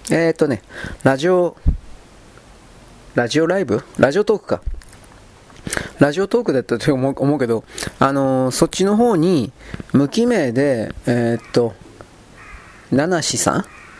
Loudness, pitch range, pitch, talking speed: -18 LUFS, 115-165 Hz, 135 Hz, 230 characters per minute